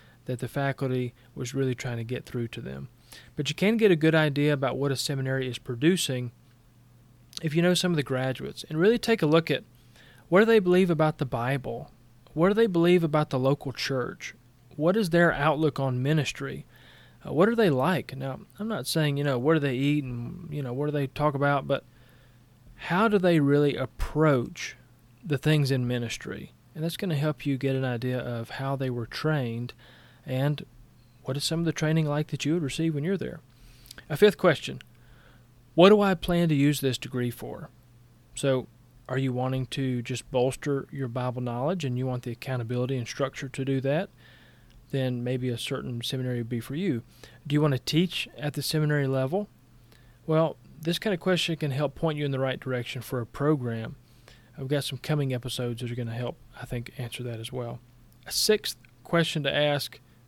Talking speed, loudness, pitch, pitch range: 205 wpm, -27 LUFS, 135 Hz, 125-155 Hz